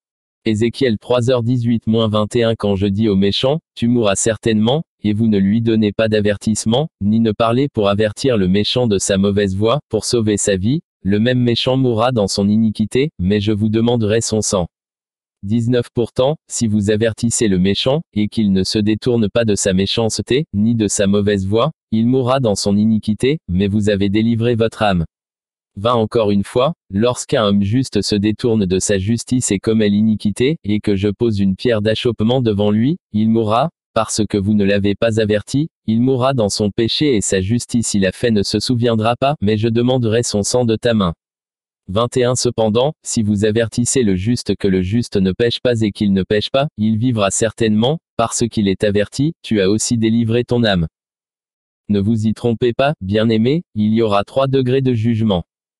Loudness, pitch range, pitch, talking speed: -16 LUFS, 105-120 Hz, 110 Hz, 190 wpm